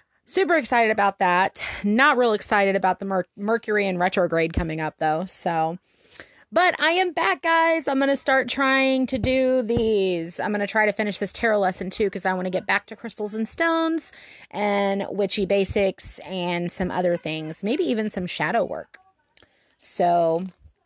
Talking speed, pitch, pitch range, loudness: 175 wpm, 205 Hz, 185-255 Hz, -22 LUFS